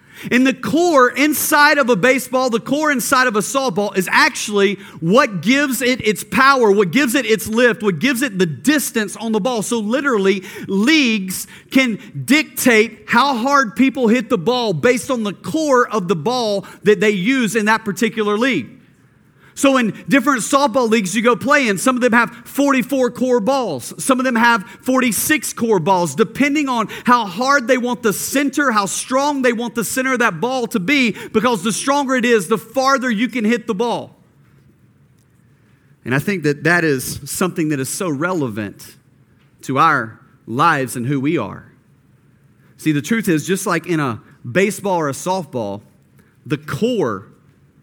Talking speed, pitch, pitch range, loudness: 180 wpm, 230 Hz, 195-260 Hz, -16 LUFS